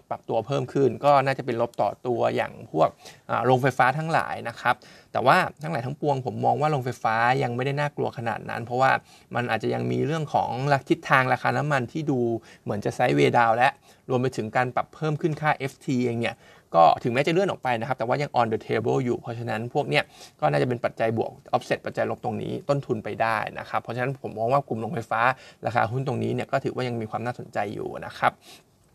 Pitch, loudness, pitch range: 125 Hz, -25 LUFS, 120-140 Hz